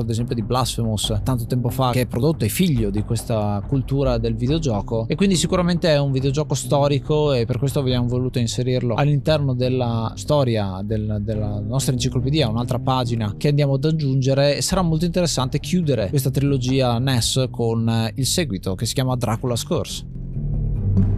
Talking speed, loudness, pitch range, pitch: 165 wpm, -21 LUFS, 115-140 Hz, 130 Hz